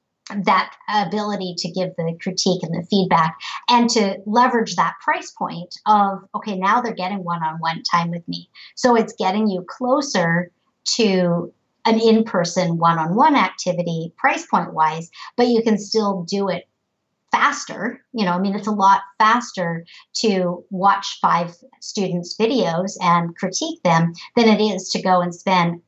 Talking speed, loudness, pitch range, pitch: 165 wpm, -19 LUFS, 175-220 Hz, 195 Hz